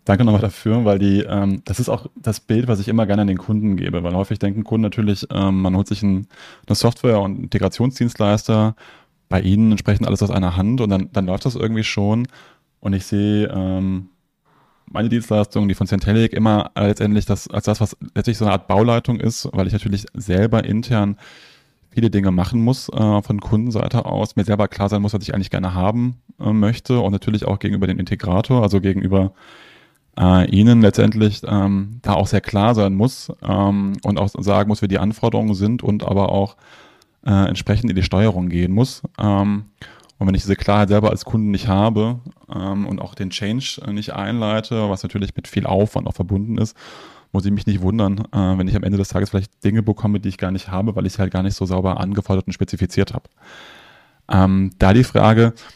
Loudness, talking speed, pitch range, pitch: -18 LUFS, 205 wpm, 100-110 Hz, 105 Hz